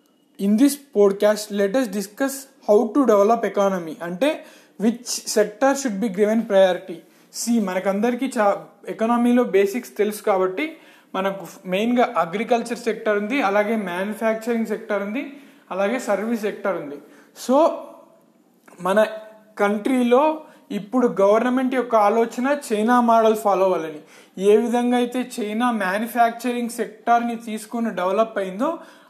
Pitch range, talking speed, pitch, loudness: 205-250 Hz, 120 wpm, 225 Hz, -21 LUFS